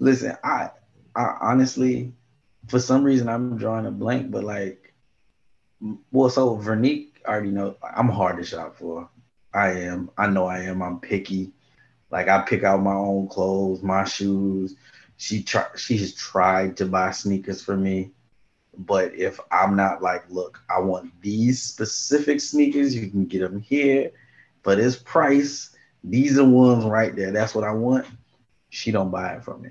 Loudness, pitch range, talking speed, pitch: -22 LUFS, 95-125 Hz, 170 wpm, 100 Hz